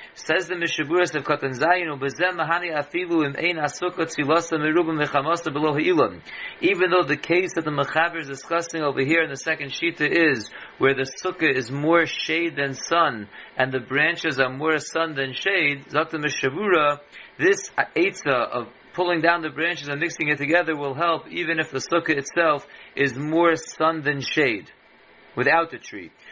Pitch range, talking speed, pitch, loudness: 145-170 Hz, 180 wpm, 160 Hz, -22 LUFS